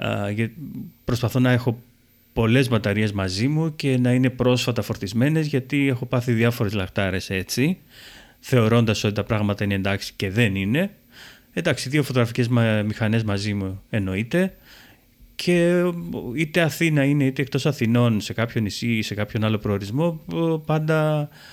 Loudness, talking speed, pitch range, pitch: -22 LUFS, 140 wpm, 105-140 Hz, 120 Hz